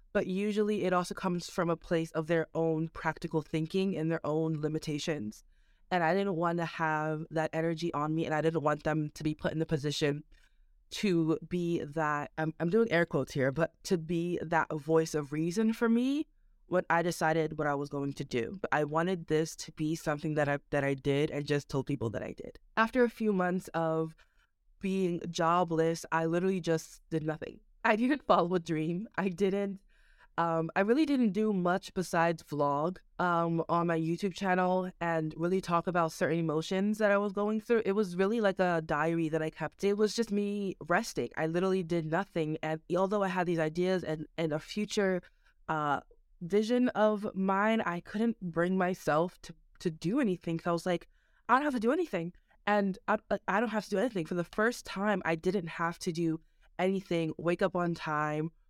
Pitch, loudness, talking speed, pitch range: 170 Hz, -32 LUFS, 205 wpm, 160-195 Hz